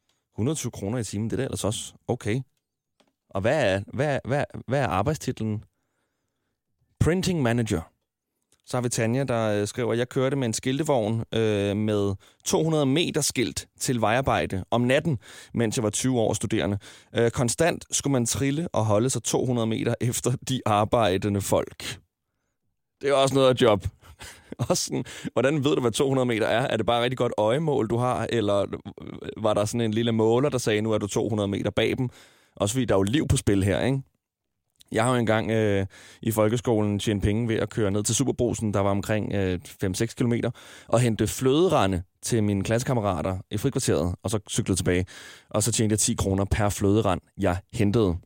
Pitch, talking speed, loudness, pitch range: 110 Hz, 190 wpm, -25 LUFS, 100-125 Hz